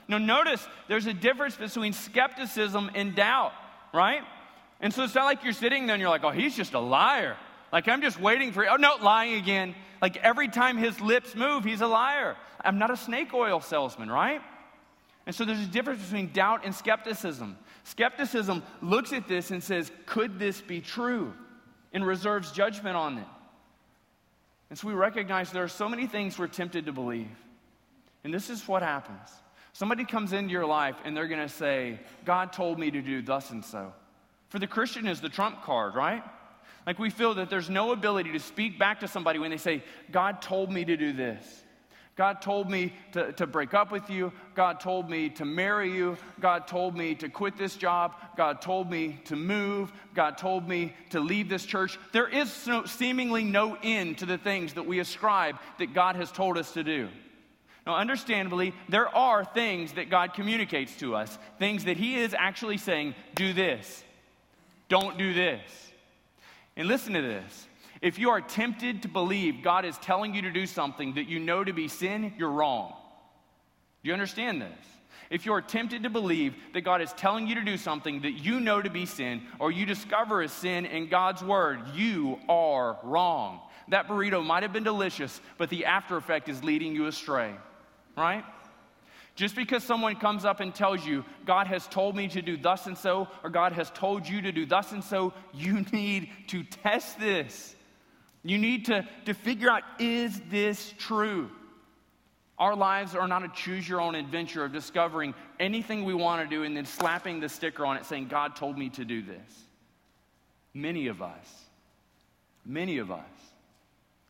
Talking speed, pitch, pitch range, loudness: 190 wpm, 190 Hz, 170-215 Hz, -29 LUFS